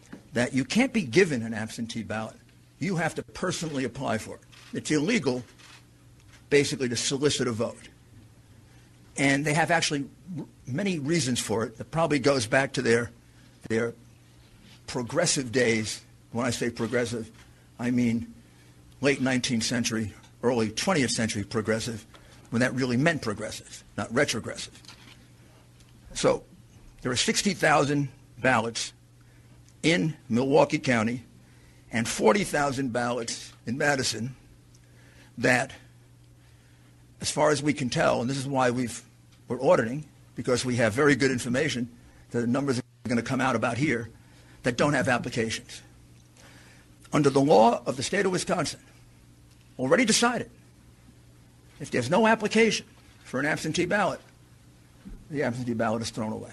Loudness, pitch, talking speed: -26 LUFS, 120 Hz, 140 wpm